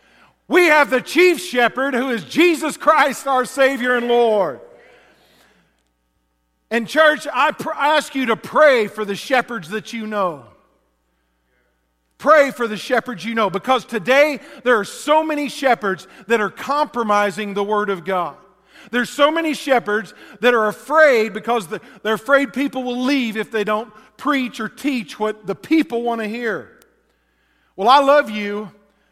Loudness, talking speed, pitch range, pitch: -18 LUFS, 160 wpm, 210-280 Hz, 235 Hz